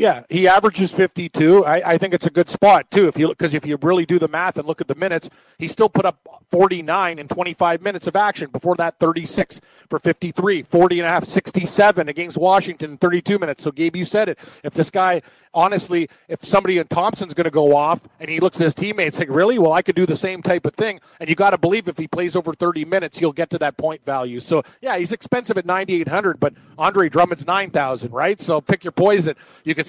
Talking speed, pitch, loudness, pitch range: 240 wpm, 175 Hz, -18 LUFS, 160-190 Hz